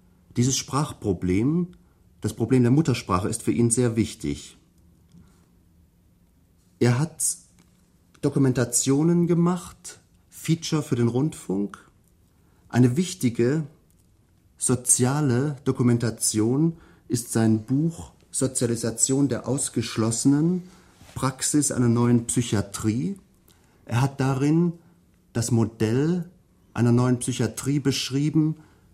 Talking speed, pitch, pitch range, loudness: 85 wpm, 120 Hz, 105-140 Hz, -24 LUFS